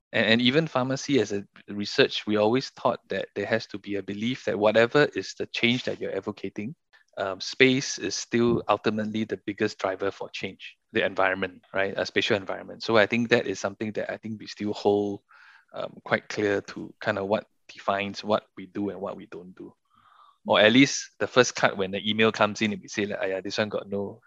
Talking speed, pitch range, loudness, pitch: 220 wpm, 100-120 Hz, -26 LUFS, 110 Hz